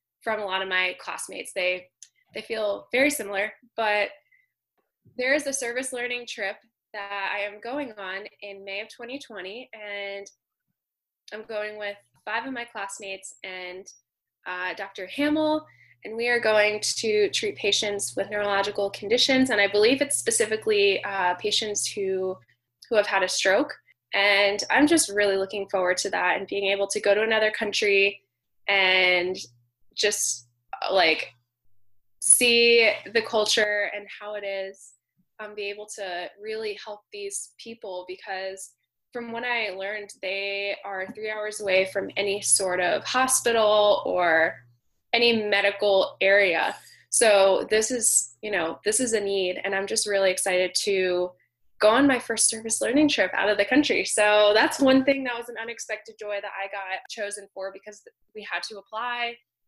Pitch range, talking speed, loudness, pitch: 195-230 Hz, 160 wpm, -24 LUFS, 205 Hz